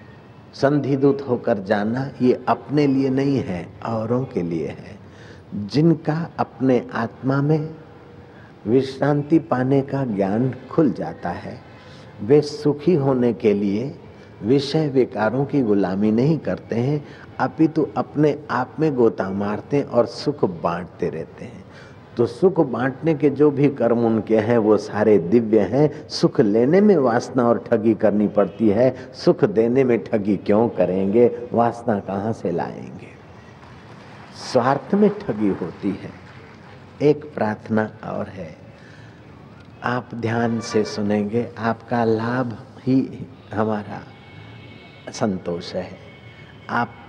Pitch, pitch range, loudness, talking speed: 120 Hz, 110-140 Hz, -20 LUFS, 125 wpm